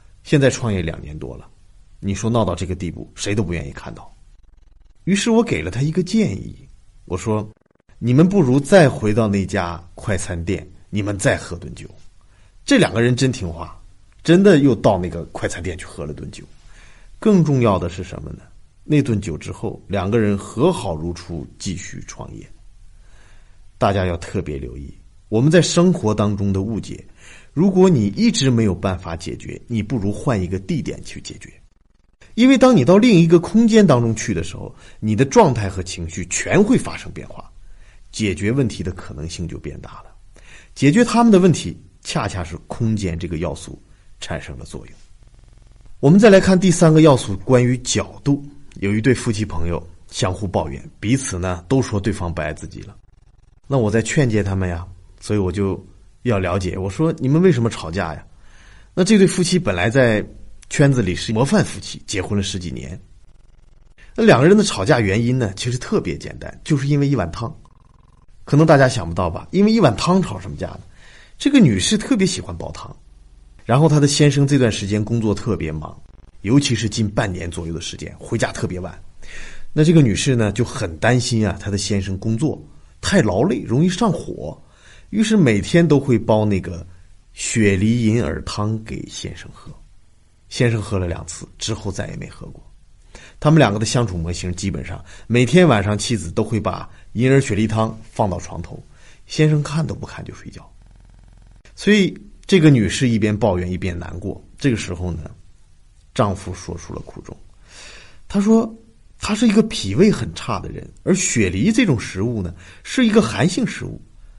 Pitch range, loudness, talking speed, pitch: 90-135 Hz, -18 LUFS, 270 characters per minute, 105 Hz